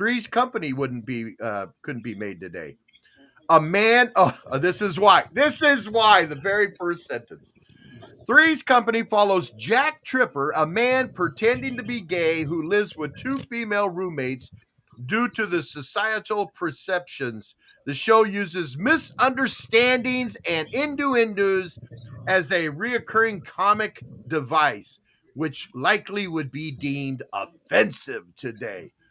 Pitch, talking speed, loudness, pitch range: 195 Hz, 130 wpm, -22 LUFS, 150-230 Hz